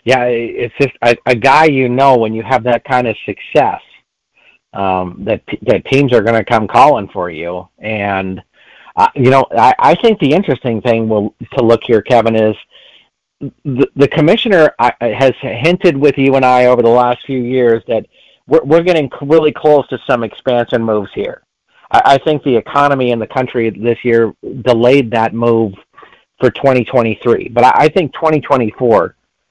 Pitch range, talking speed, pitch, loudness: 115-140 Hz, 185 wpm, 125 Hz, -12 LUFS